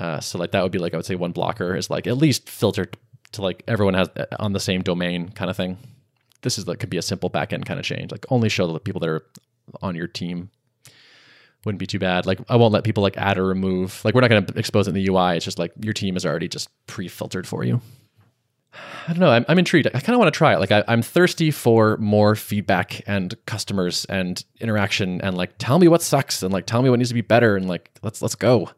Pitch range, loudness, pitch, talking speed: 95-125 Hz, -21 LUFS, 105 Hz, 265 wpm